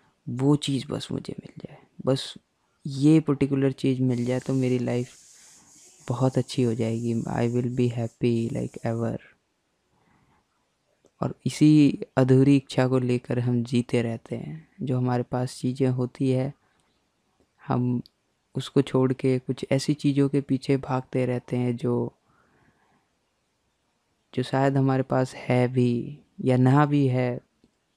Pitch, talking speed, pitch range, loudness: 130 Hz, 135 wpm, 125-135 Hz, -25 LUFS